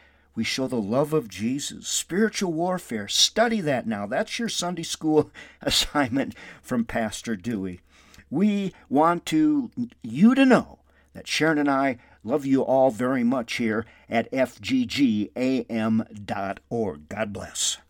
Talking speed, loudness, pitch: 130 wpm, -24 LUFS, 150 Hz